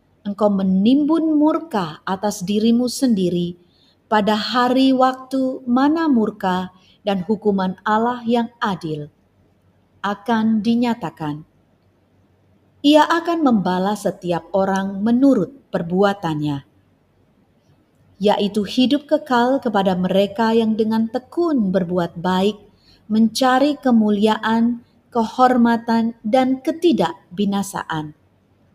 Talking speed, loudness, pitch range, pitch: 85 wpm, -19 LUFS, 185-245 Hz, 210 Hz